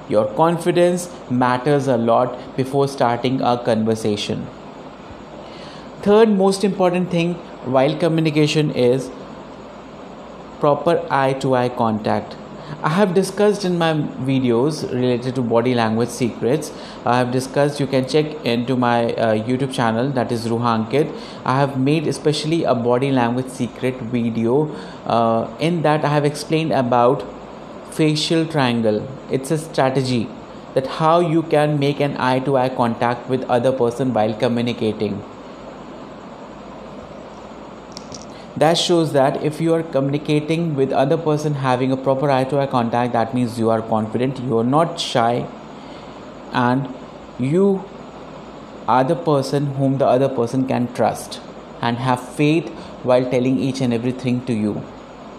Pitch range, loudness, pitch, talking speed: 120-150 Hz, -19 LUFS, 130 Hz, 140 wpm